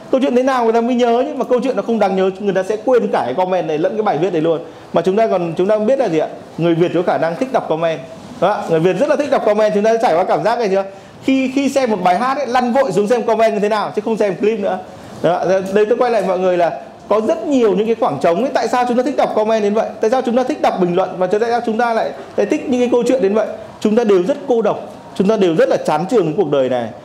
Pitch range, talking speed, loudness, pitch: 185-245 Hz, 330 wpm, -16 LUFS, 220 Hz